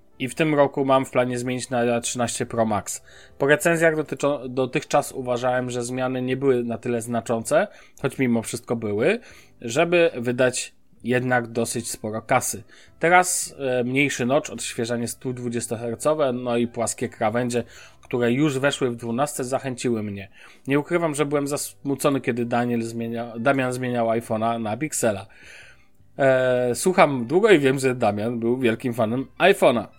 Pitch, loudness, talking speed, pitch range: 125 Hz, -23 LUFS, 150 wpm, 120-140 Hz